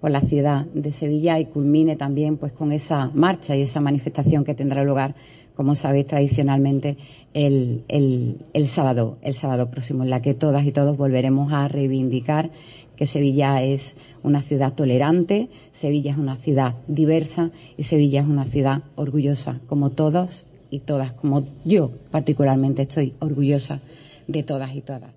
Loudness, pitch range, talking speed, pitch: -21 LUFS, 135-150 Hz, 160 wpm, 145 Hz